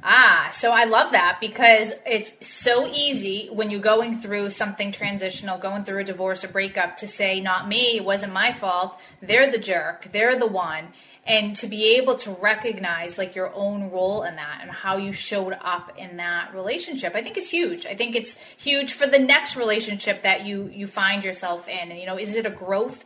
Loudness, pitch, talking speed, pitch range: -22 LUFS, 205 Hz, 210 wpm, 190-230 Hz